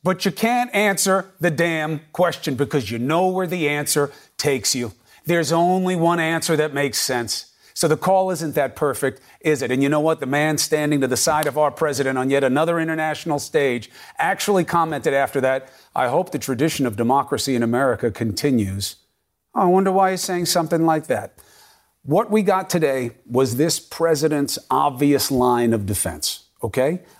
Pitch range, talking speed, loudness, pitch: 130-170 Hz, 180 wpm, -20 LUFS, 150 Hz